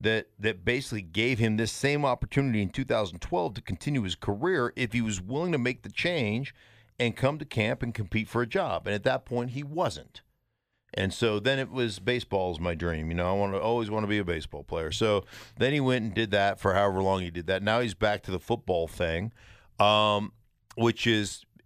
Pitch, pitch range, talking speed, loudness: 110 Hz, 100-120 Hz, 225 wpm, -28 LUFS